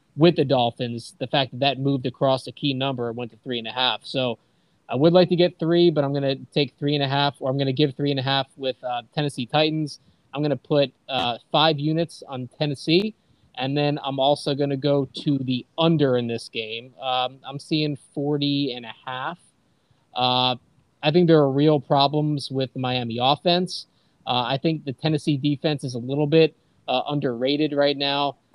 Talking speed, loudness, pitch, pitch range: 215 wpm, -23 LUFS, 140 Hz, 130-150 Hz